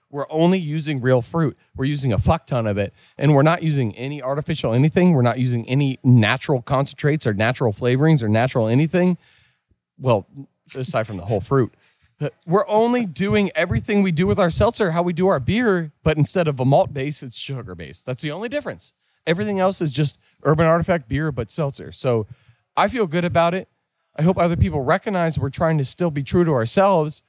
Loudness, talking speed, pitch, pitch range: -20 LUFS, 205 wpm, 145 Hz, 125-175 Hz